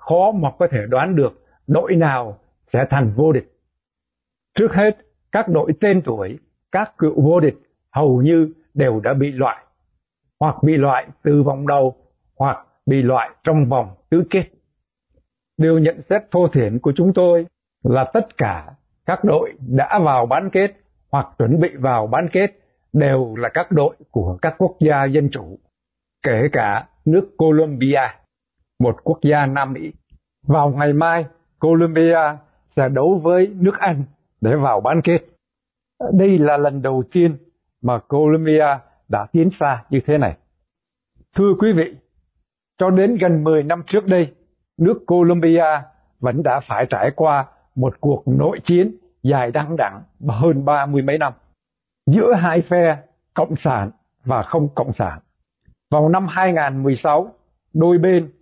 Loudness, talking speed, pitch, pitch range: -17 LUFS, 155 wpm, 155 Hz, 135-170 Hz